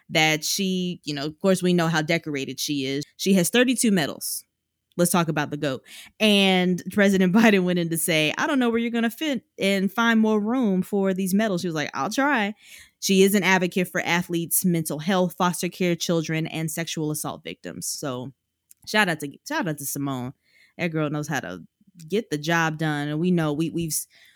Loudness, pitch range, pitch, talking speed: -23 LUFS, 155-195 Hz, 175 Hz, 210 wpm